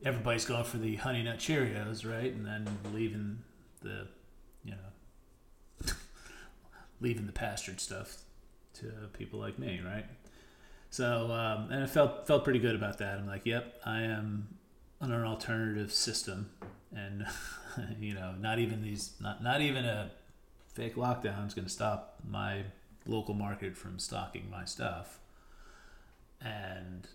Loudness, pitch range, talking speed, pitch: -36 LUFS, 100-115 Hz, 145 wpm, 110 Hz